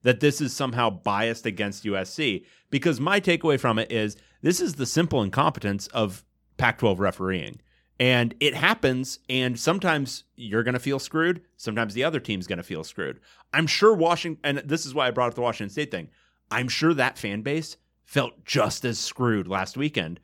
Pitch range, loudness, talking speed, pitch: 110-155 Hz, -25 LUFS, 185 wpm, 125 Hz